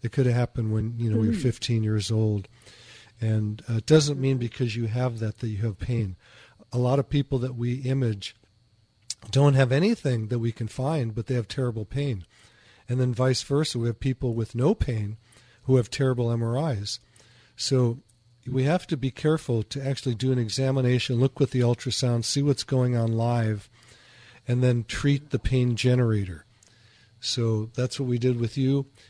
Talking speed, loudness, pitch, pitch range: 190 wpm, -26 LUFS, 120 Hz, 115-130 Hz